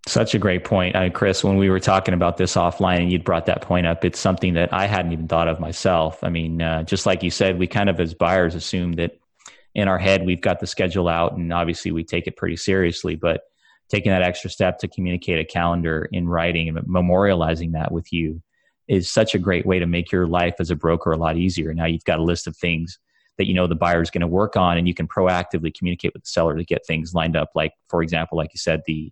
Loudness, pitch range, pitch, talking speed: -21 LUFS, 85-95 Hz, 90 Hz, 260 wpm